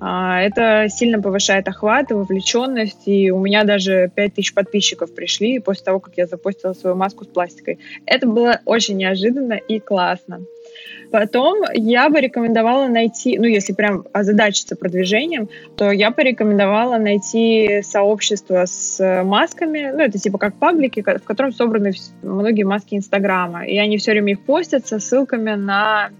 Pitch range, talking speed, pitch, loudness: 195-230 Hz, 150 wpm, 210 Hz, -17 LUFS